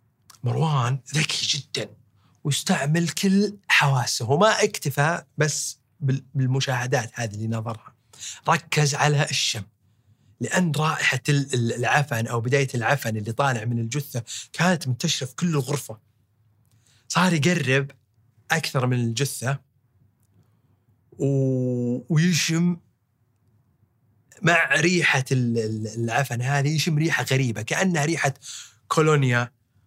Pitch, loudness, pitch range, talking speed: 130 Hz, -23 LUFS, 115-150 Hz, 95 wpm